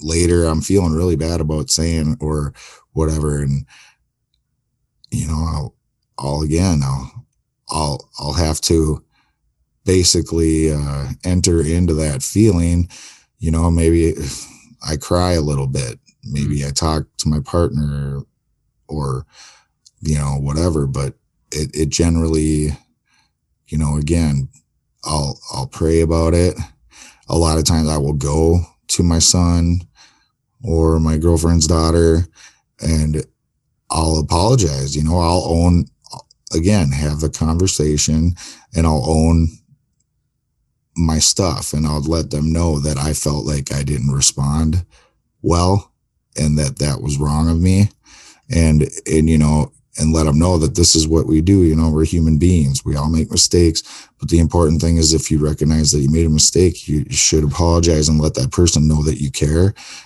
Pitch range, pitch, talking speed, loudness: 75-85 Hz, 80 Hz, 155 wpm, -16 LUFS